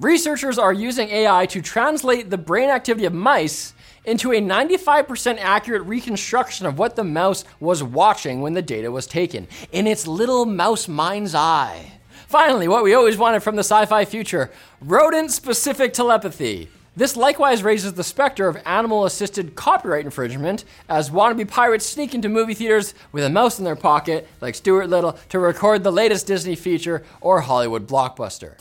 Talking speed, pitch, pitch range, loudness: 170 wpm, 205 Hz, 175-235 Hz, -19 LUFS